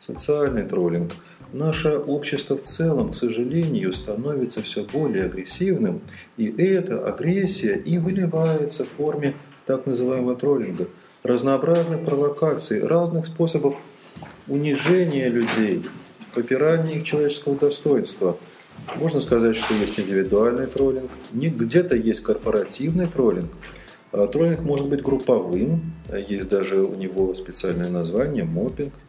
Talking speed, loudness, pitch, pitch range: 110 wpm, -23 LUFS, 145 Hz, 125-165 Hz